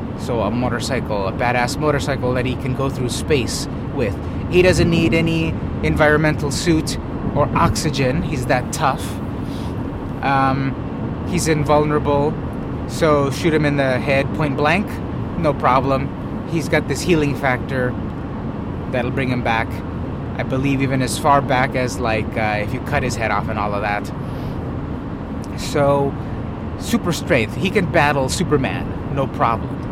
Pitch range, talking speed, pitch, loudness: 115-140 Hz, 150 wpm, 130 Hz, -19 LUFS